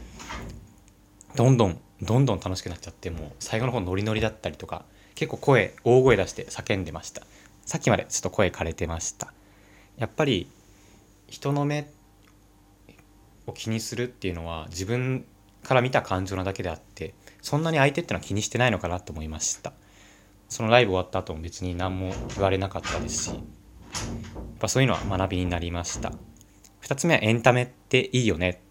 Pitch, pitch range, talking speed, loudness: 100 Hz, 95-115 Hz, 370 characters per minute, -26 LUFS